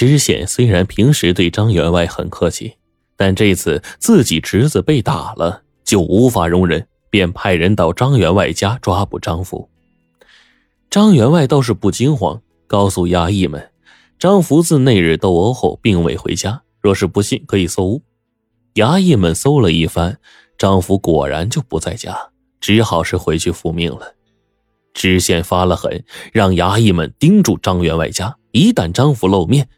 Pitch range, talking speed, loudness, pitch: 85-120 Hz, 235 characters per minute, -14 LUFS, 100 Hz